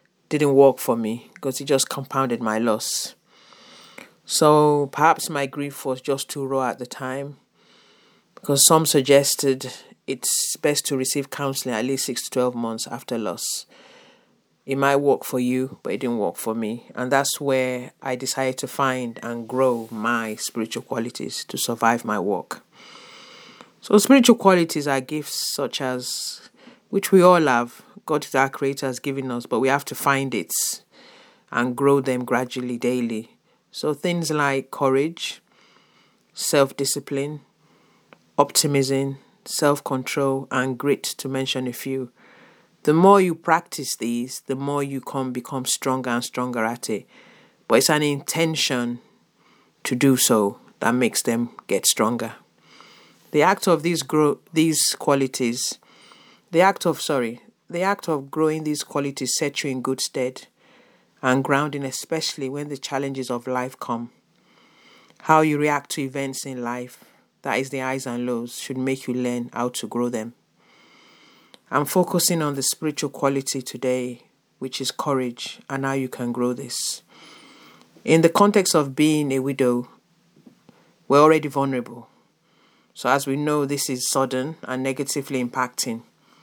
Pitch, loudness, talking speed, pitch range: 135 Hz, -22 LUFS, 155 wpm, 125-145 Hz